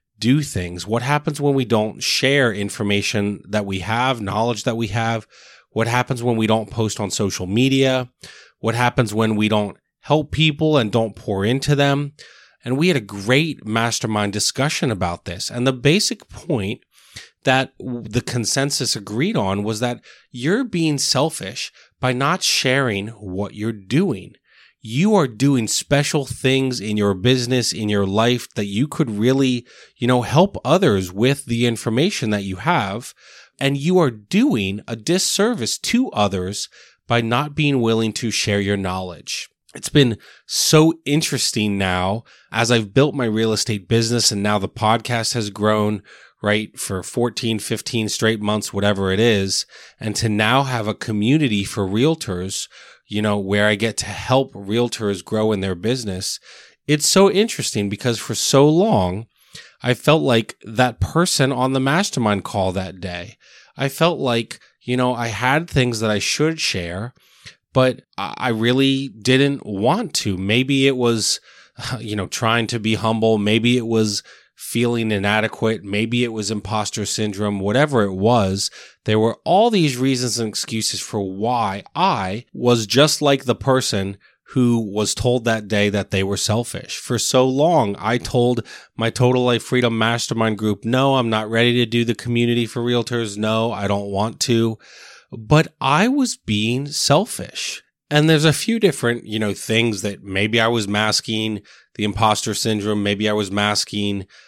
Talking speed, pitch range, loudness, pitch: 165 wpm, 105-130 Hz, -19 LUFS, 115 Hz